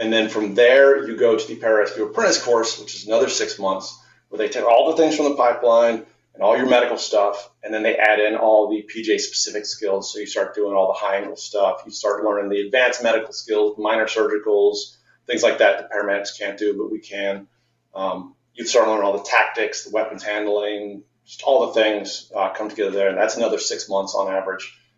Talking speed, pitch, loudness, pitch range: 225 wpm, 110 Hz, -20 LUFS, 100-160 Hz